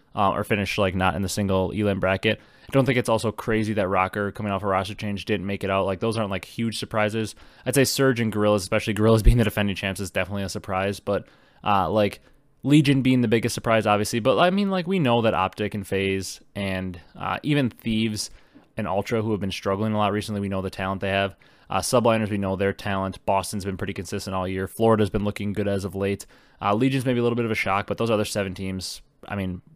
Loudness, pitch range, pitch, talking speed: -24 LUFS, 95-115 Hz, 105 Hz, 245 wpm